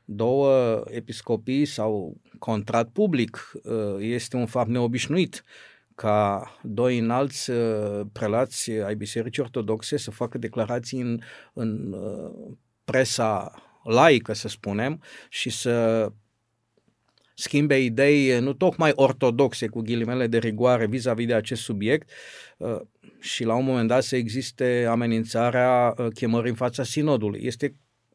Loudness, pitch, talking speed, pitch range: -24 LUFS, 120 Hz, 115 wpm, 110-130 Hz